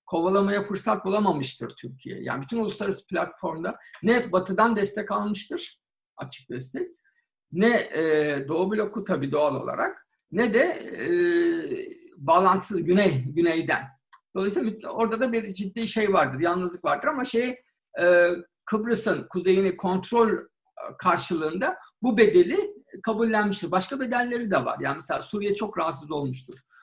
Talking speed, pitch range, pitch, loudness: 120 wpm, 175-235 Hz, 200 Hz, -25 LUFS